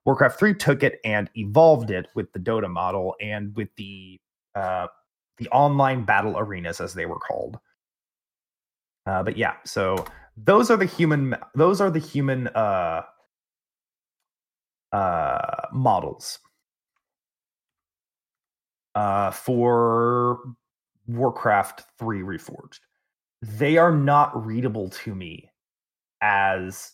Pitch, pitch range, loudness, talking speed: 120 Hz, 105-145 Hz, -22 LUFS, 110 wpm